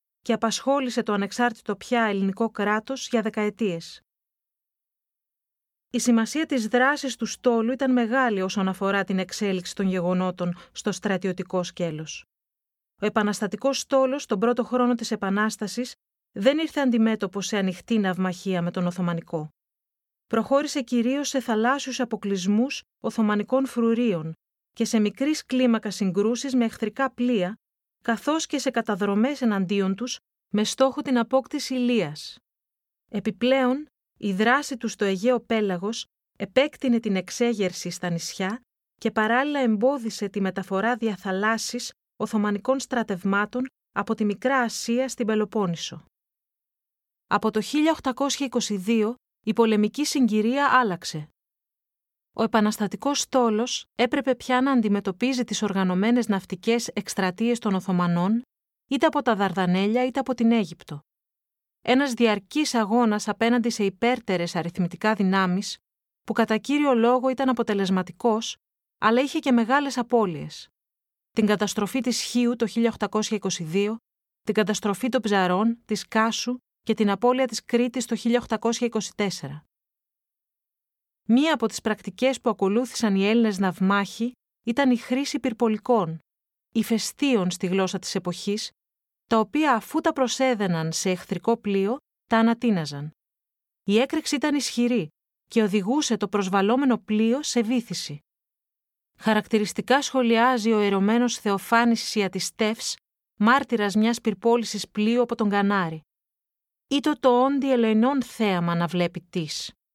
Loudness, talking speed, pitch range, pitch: -24 LUFS, 120 wpm, 200-245 Hz, 225 Hz